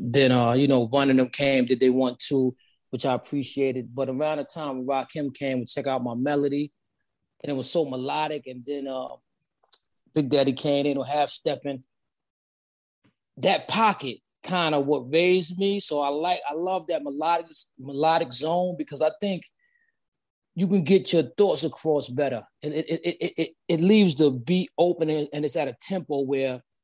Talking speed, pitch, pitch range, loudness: 195 wpm, 145 Hz, 135-165 Hz, -25 LUFS